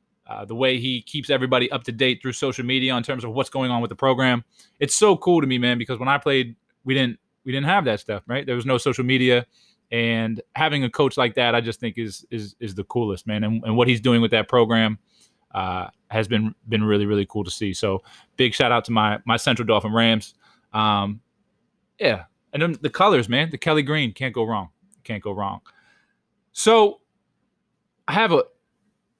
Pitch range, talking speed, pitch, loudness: 110-135 Hz, 220 wpm, 125 Hz, -21 LUFS